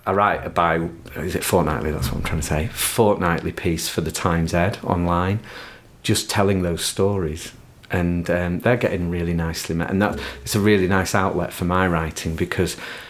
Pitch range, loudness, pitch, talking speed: 80-95 Hz, -21 LUFS, 85 Hz, 190 wpm